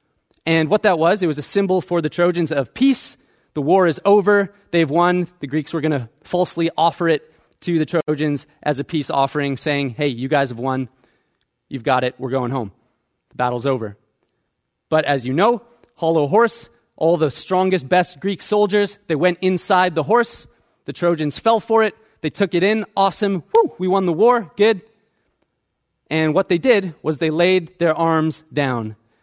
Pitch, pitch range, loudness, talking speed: 165 Hz, 145-190 Hz, -19 LUFS, 190 wpm